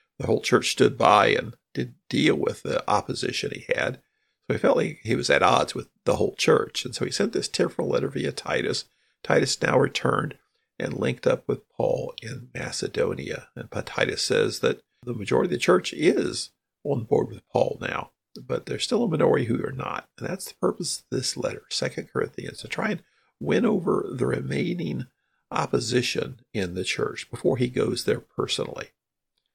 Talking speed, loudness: 185 wpm, -25 LUFS